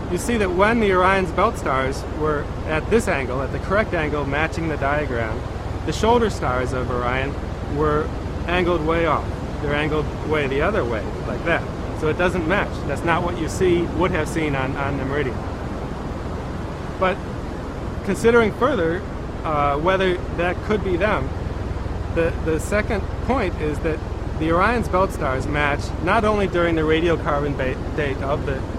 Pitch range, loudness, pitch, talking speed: 120-185 Hz, -22 LUFS, 150 Hz, 165 wpm